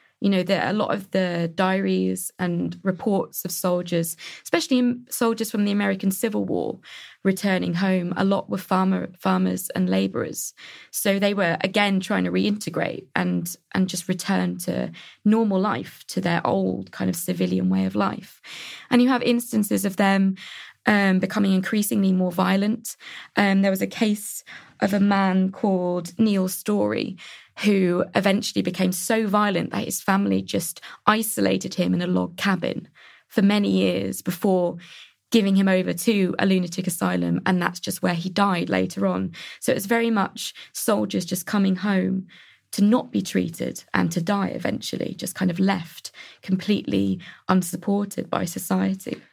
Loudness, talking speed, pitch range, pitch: -23 LUFS, 160 wpm, 170-205 Hz, 190 Hz